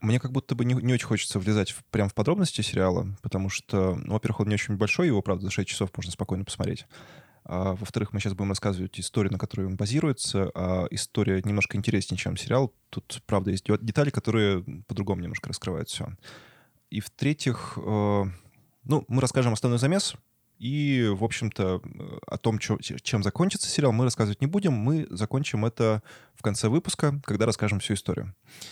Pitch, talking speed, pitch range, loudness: 110 Hz, 180 wpm, 100-130 Hz, -27 LUFS